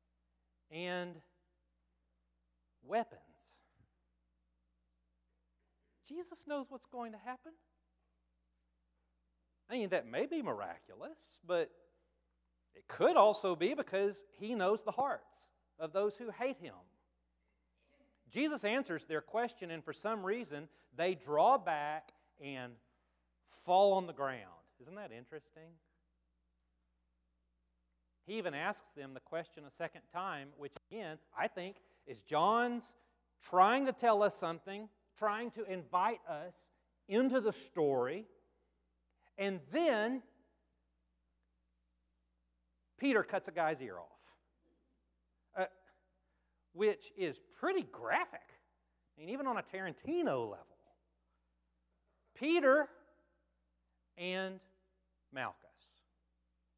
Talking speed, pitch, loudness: 105 wpm, 155 Hz, -37 LUFS